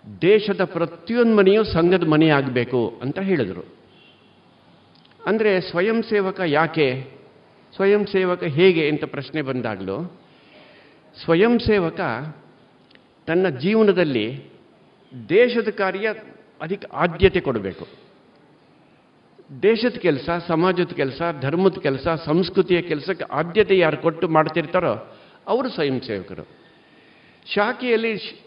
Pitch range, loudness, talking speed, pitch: 155-200 Hz, -20 LUFS, 90 wpm, 175 Hz